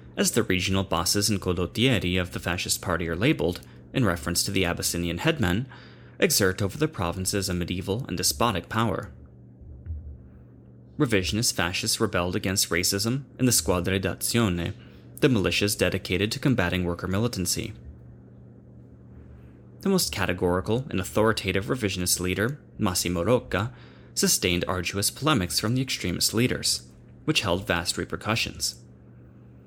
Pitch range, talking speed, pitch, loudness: 80-105 Hz, 125 wpm, 90 Hz, -25 LUFS